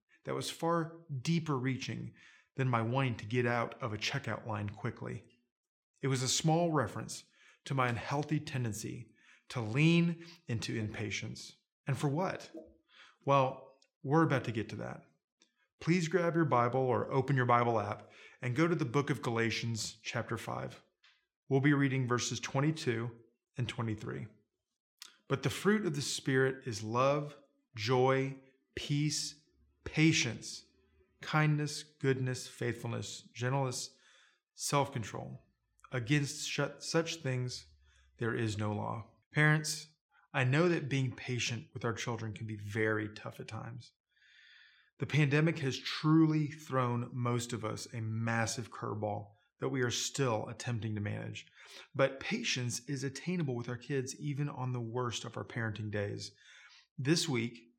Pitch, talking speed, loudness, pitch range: 130 Hz, 145 wpm, -34 LUFS, 115-145 Hz